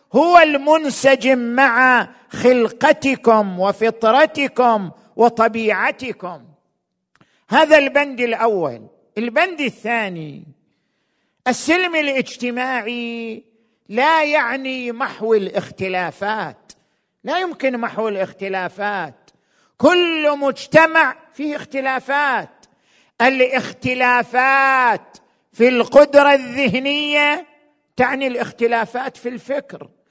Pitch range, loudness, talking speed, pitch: 225-280 Hz, -16 LUFS, 65 wpm, 250 Hz